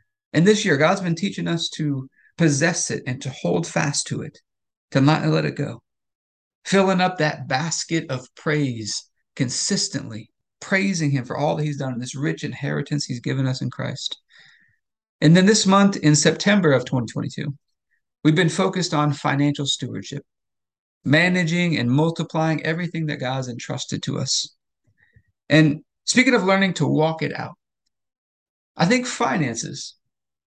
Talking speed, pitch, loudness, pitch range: 155 wpm, 150 Hz, -21 LUFS, 135-170 Hz